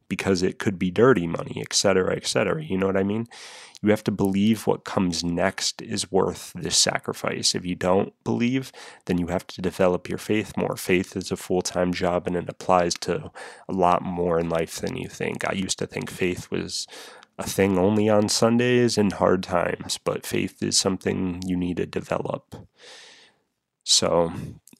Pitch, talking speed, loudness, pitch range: 95 Hz, 190 wpm, -24 LUFS, 90-105 Hz